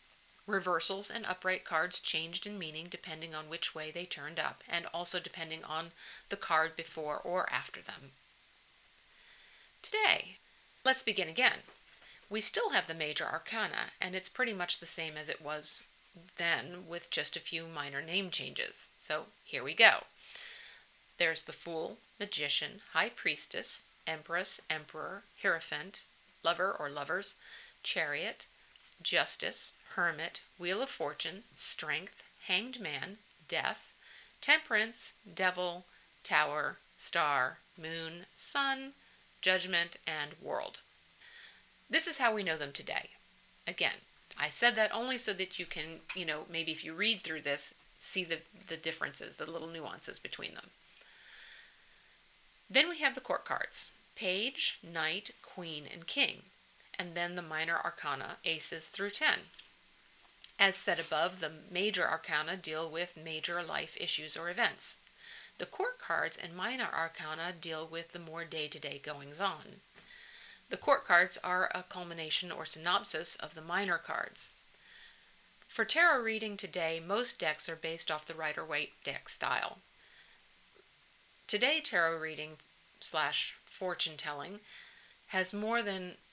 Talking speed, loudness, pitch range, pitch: 135 wpm, -34 LUFS, 160-205 Hz, 175 Hz